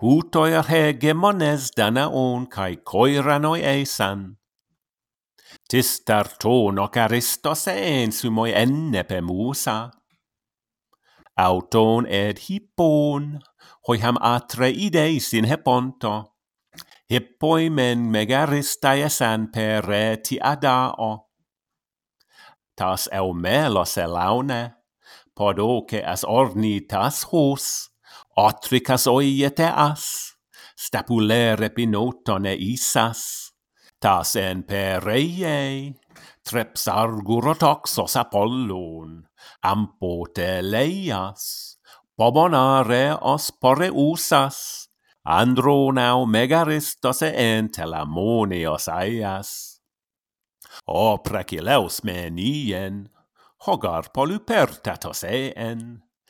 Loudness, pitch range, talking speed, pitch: -21 LUFS, 105-140 Hz, 80 wpm, 120 Hz